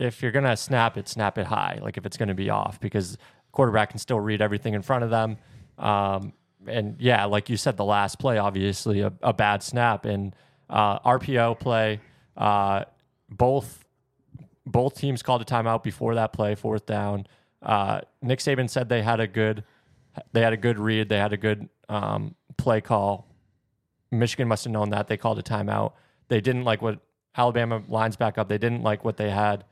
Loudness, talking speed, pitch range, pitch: -25 LUFS, 195 wpm, 105-120 Hz, 110 Hz